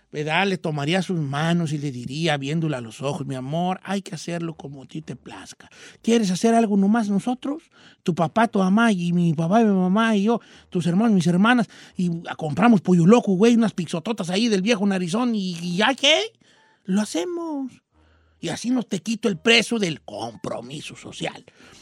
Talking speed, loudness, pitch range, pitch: 185 wpm, -22 LUFS, 165-230 Hz, 190 Hz